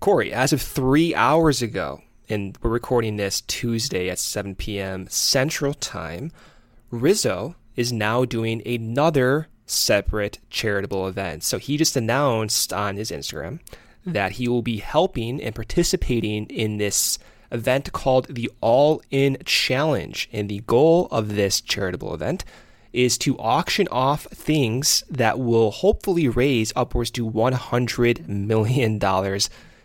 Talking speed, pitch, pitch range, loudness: 135 wpm, 115 Hz, 105-130 Hz, -22 LUFS